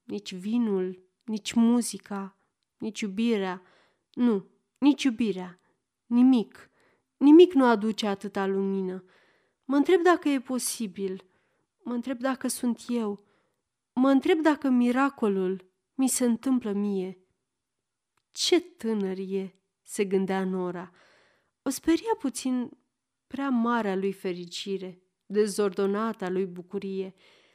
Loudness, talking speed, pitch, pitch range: -26 LUFS, 105 wpm, 215 Hz, 190-260 Hz